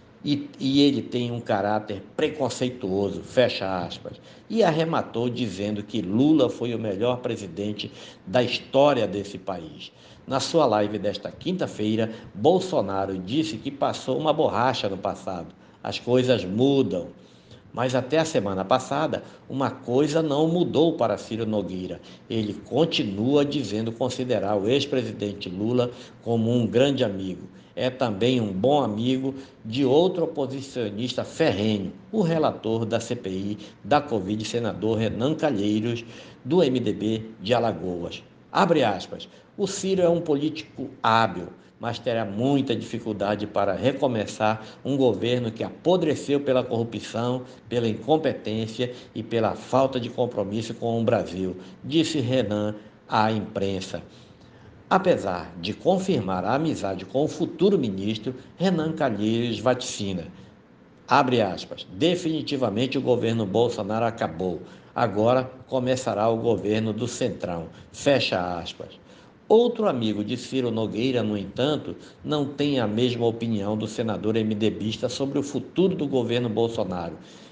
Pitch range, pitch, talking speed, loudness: 105-130 Hz, 115 Hz, 130 wpm, -25 LUFS